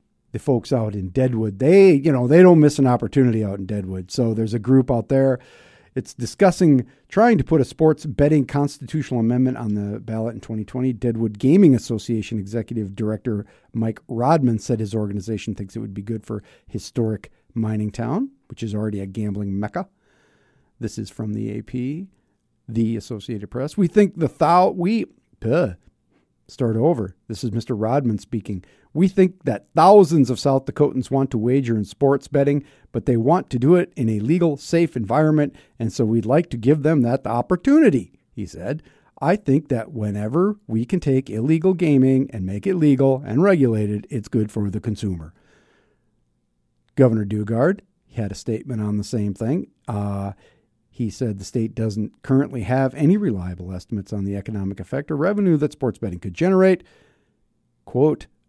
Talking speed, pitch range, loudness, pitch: 175 wpm, 110-145 Hz, -20 LUFS, 120 Hz